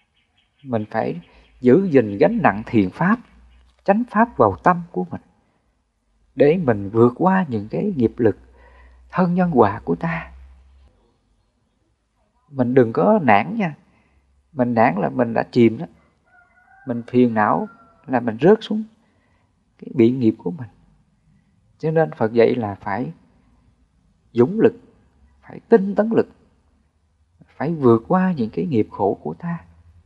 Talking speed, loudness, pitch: 145 wpm, -19 LUFS, 115 Hz